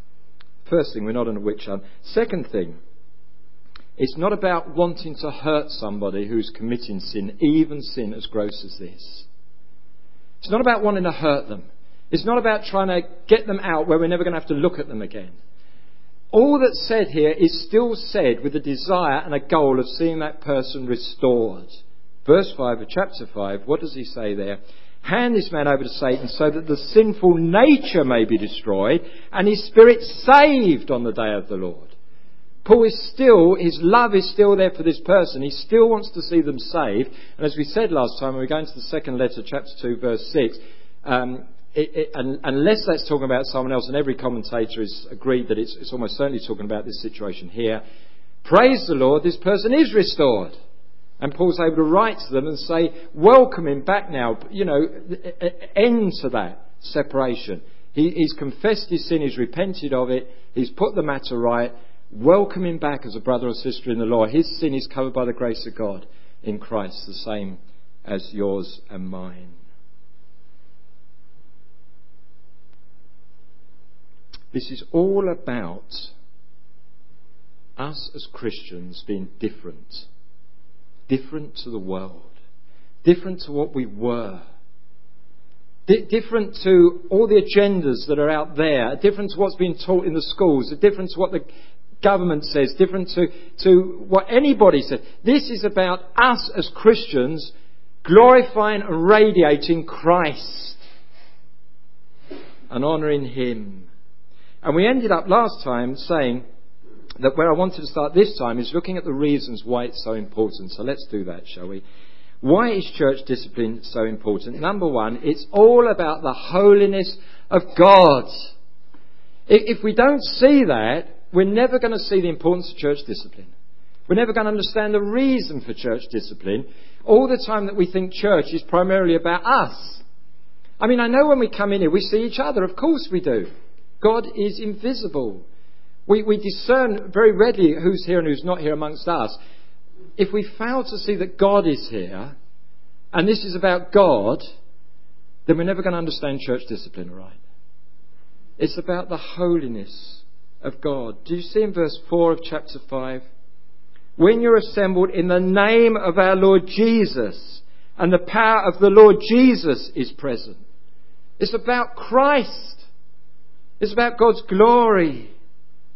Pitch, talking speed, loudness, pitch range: 155 Hz, 170 wpm, -19 LUFS, 130-195 Hz